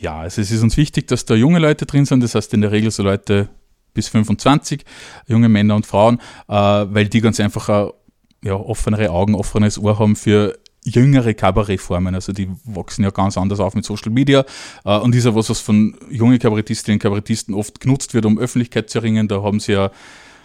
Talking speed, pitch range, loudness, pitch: 205 wpm, 100-115 Hz, -16 LUFS, 110 Hz